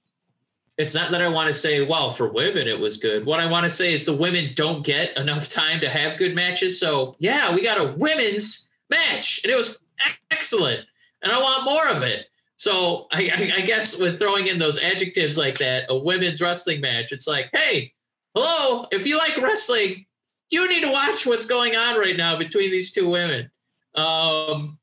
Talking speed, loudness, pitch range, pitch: 200 wpm, -21 LUFS, 155-250 Hz, 185 Hz